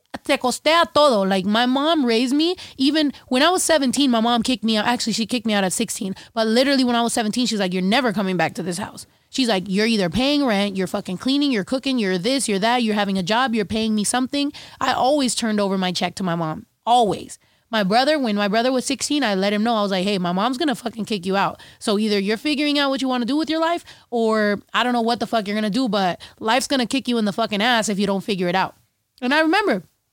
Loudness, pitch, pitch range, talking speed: -20 LUFS, 230 Hz, 205-260 Hz, 270 wpm